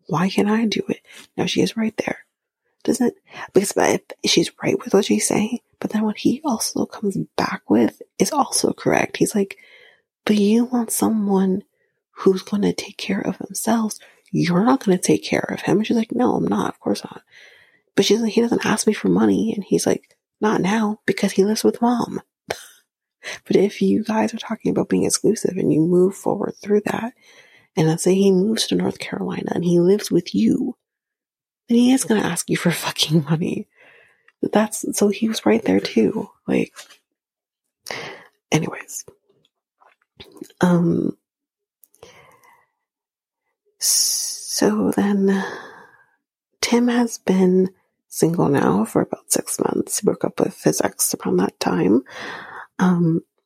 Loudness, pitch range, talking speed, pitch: -20 LUFS, 195-245 Hz, 165 wpm, 215 Hz